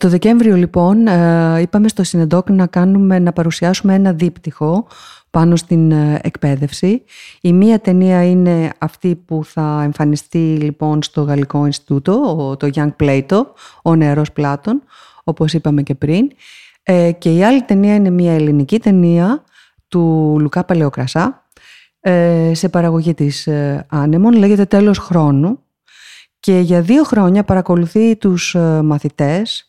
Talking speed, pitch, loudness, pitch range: 125 wpm, 170 Hz, -13 LUFS, 150-190 Hz